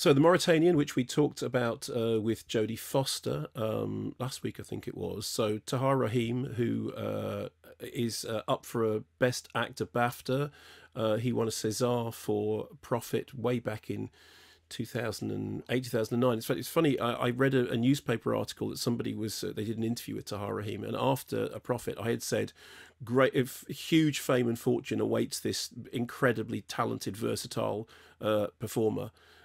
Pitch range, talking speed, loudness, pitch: 110-130 Hz, 175 wpm, -31 LUFS, 120 Hz